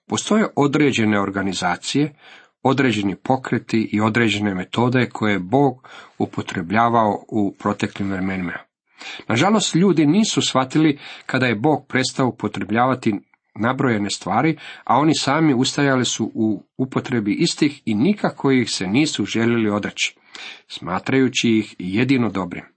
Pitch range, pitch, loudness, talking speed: 105-140 Hz, 120 Hz, -20 LUFS, 120 wpm